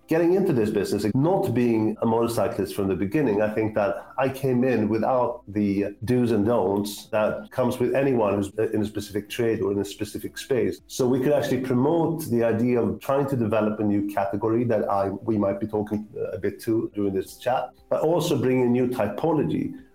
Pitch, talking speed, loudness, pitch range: 115 Hz, 205 wpm, -24 LUFS, 105-125 Hz